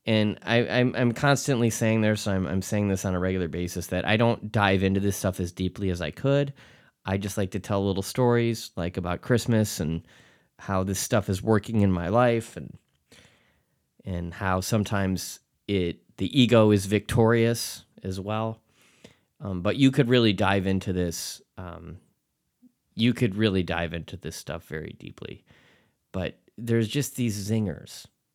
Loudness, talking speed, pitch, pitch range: -25 LUFS, 170 wpm, 100 Hz, 95-115 Hz